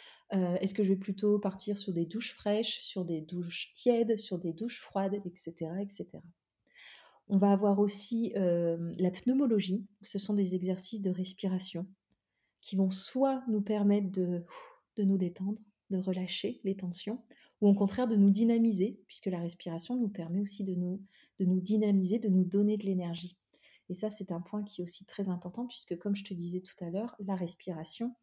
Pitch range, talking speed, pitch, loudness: 185-210 Hz, 190 wpm, 195 Hz, -33 LUFS